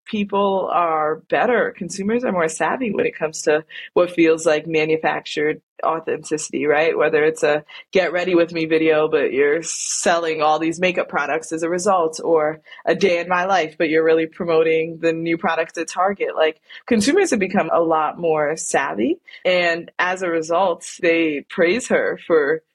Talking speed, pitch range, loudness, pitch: 175 wpm, 160-195 Hz, -19 LUFS, 165 Hz